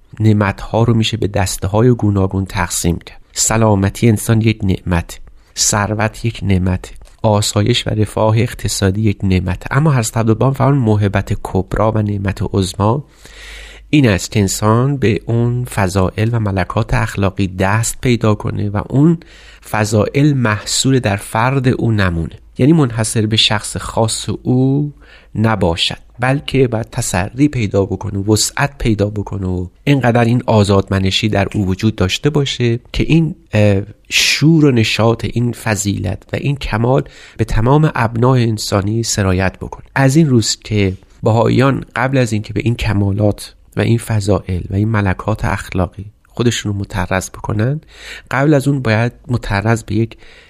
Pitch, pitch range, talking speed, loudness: 110 Hz, 100-120 Hz, 150 wpm, -15 LUFS